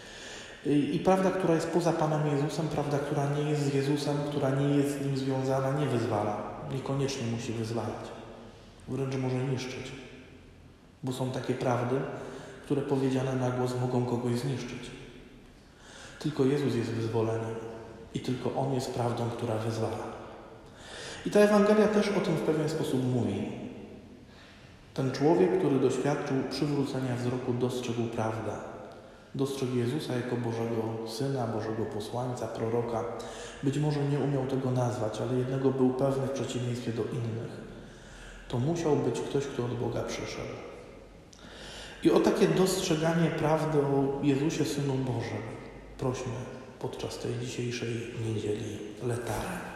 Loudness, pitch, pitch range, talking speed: -30 LUFS, 130 Hz, 115-140 Hz, 135 wpm